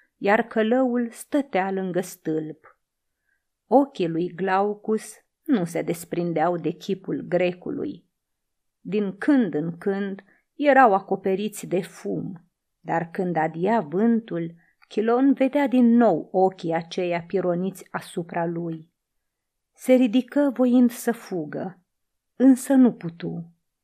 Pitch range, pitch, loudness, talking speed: 175-240 Hz, 195 Hz, -23 LUFS, 110 wpm